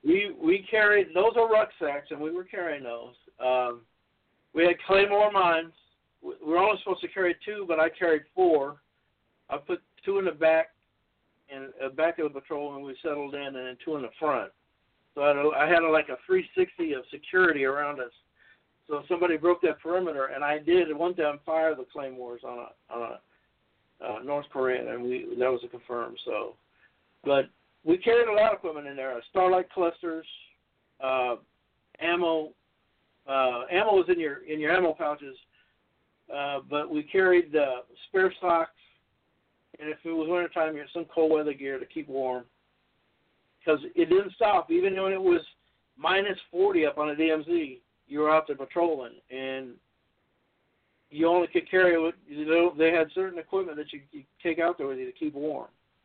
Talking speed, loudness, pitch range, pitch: 190 wpm, -27 LUFS, 140-185 Hz, 160 Hz